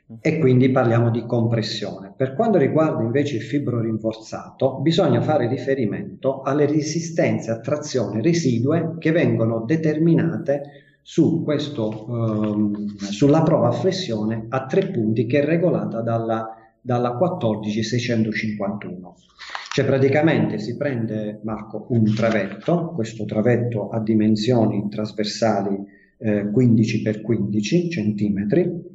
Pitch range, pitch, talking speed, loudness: 110-150 Hz, 120 Hz, 110 wpm, -21 LUFS